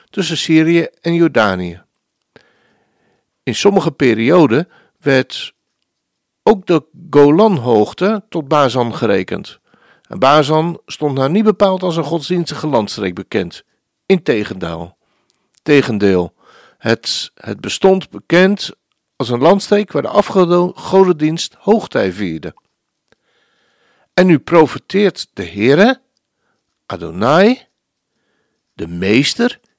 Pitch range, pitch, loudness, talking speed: 140-190 Hz, 165 Hz, -14 LUFS, 95 wpm